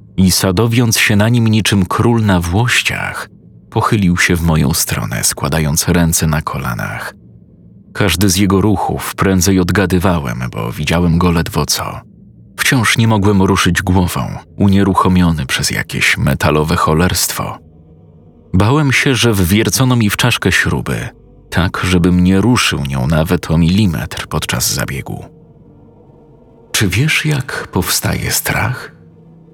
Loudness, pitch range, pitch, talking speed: -13 LUFS, 85-110 Hz, 95 Hz, 125 wpm